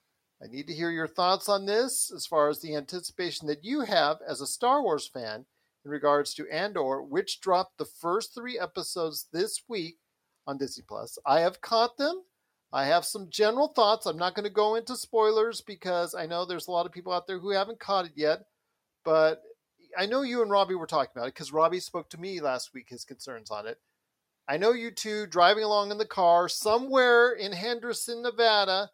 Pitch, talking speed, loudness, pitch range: 190 Hz, 210 wpm, -28 LUFS, 165-230 Hz